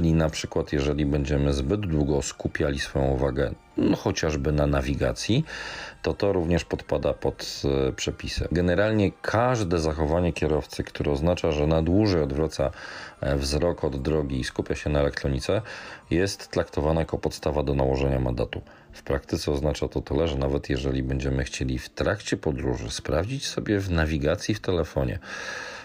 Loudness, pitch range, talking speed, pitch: -26 LUFS, 70-85 Hz, 150 wpm, 75 Hz